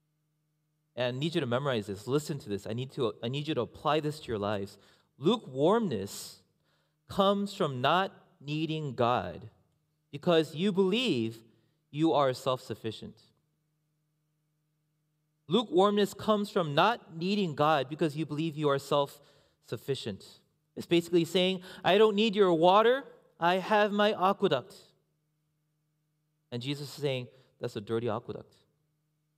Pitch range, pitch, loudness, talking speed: 135-175 Hz, 150 Hz, -29 LUFS, 140 wpm